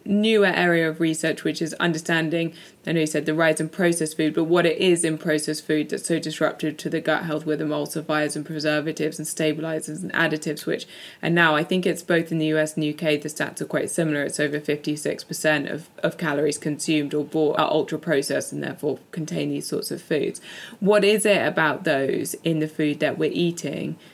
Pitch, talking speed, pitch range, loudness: 155 Hz, 210 wpm, 150-165 Hz, -23 LUFS